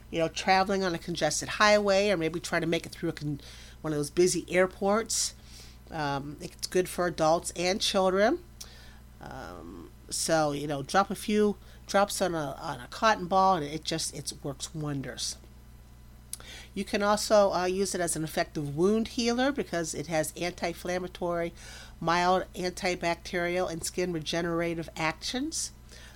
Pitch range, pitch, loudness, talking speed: 145-190 Hz, 170 Hz, -29 LUFS, 160 wpm